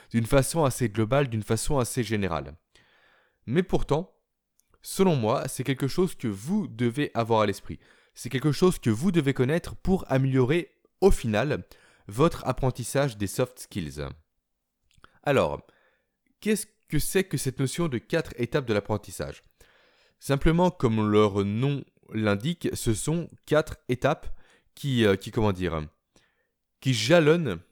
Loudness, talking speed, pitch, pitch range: -26 LUFS, 140 wpm, 130 Hz, 110-160 Hz